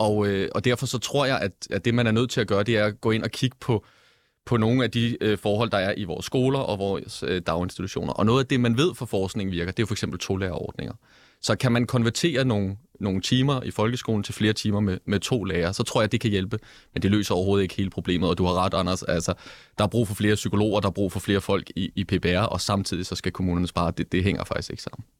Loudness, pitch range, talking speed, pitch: -25 LUFS, 95-120 Hz, 270 wpm, 105 Hz